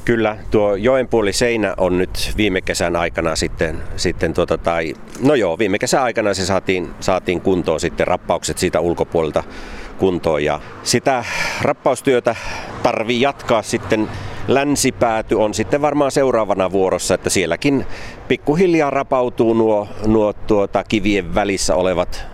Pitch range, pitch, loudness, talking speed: 95-120 Hz, 105 Hz, -18 LUFS, 130 wpm